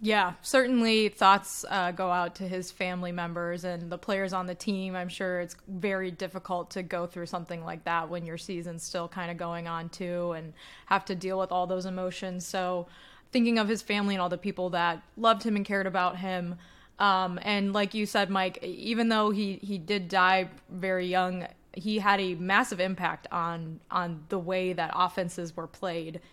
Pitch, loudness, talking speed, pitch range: 185 Hz, -29 LUFS, 200 wpm, 175-195 Hz